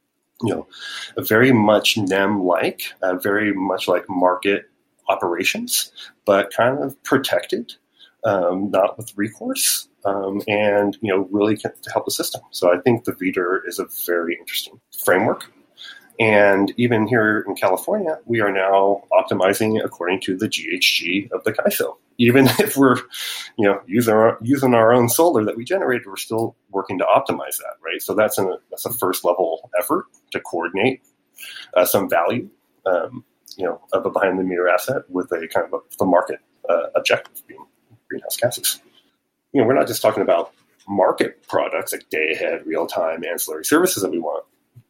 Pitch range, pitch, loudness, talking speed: 100-125 Hz, 110 Hz, -20 LUFS, 170 wpm